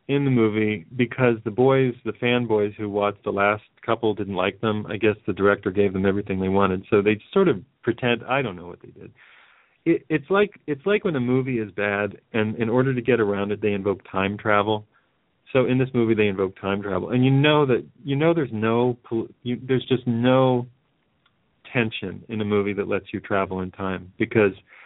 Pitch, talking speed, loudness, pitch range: 110 Hz, 210 wpm, -23 LUFS, 100-125 Hz